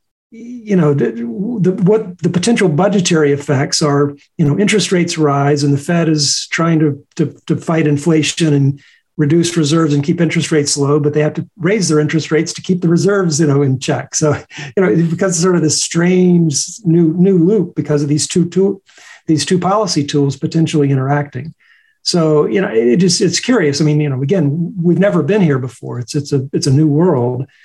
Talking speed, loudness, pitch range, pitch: 210 wpm, -14 LUFS, 145-180 Hz, 160 Hz